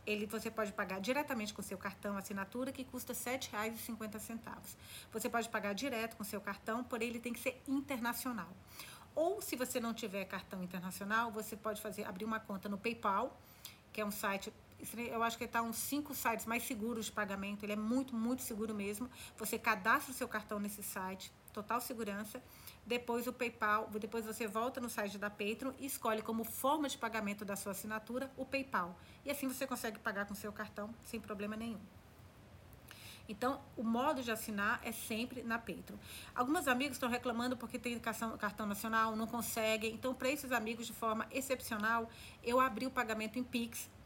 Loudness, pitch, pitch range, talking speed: -39 LUFS, 230 Hz, 215-250 Hz, 185 wpm